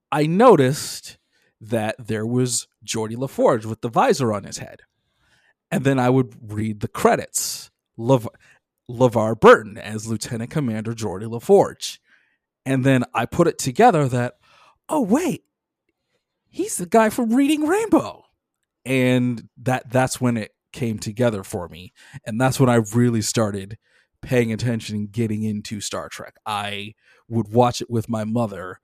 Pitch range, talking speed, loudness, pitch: 110-130 Hz, 150 wpm, -21 LUFS, 120 Hz